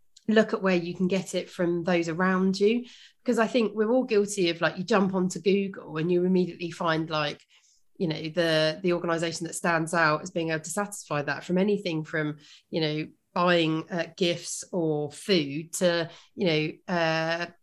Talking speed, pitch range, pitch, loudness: 190 wpm, 160-190 Hz, 175 Hz, -27 LUFS